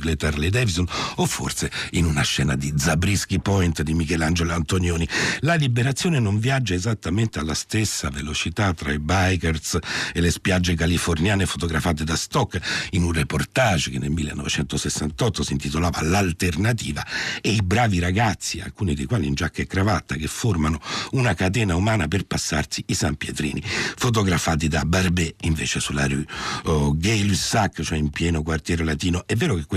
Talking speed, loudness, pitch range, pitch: 160 wpm, -22 LUFS, 80-100 Hz, 85 Hz